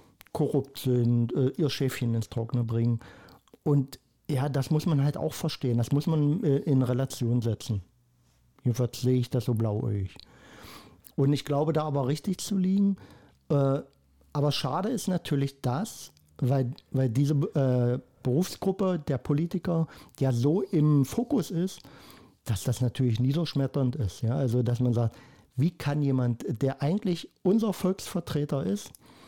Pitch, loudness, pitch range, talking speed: 135 Hz, -28 LUFS, 120-155 Hz, 140 wpm